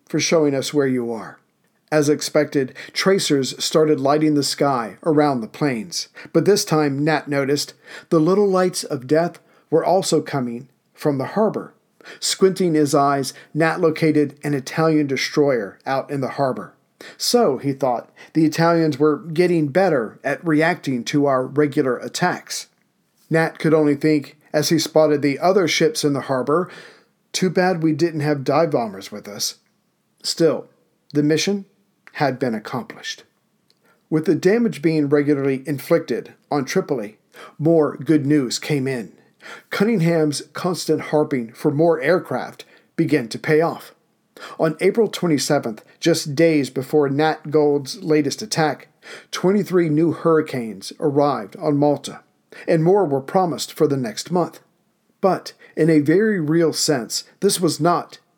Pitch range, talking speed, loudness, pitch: 140-165 Hz, 145 wpm, -20 LUFS, 155 Hz